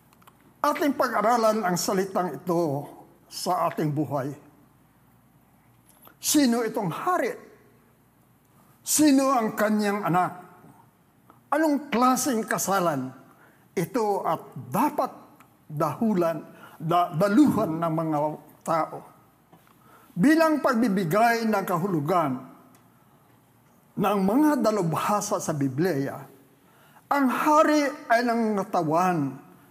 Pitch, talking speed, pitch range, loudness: 200 Hz, 80 wpm, 165-255 Hz, -24 LUFS